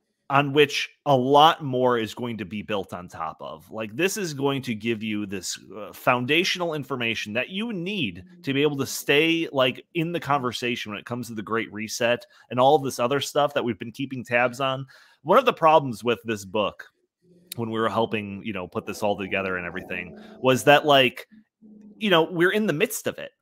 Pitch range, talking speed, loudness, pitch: 110-155 Hz, 220 wpm, -24 LUFS, 130 Hz